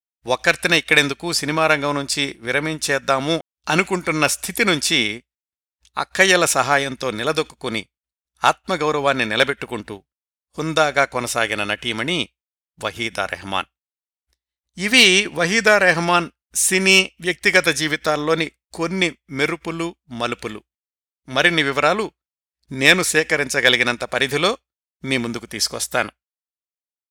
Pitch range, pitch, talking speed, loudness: 120-165 Hz, 145 Hz, 75 wpm, -18 LUFS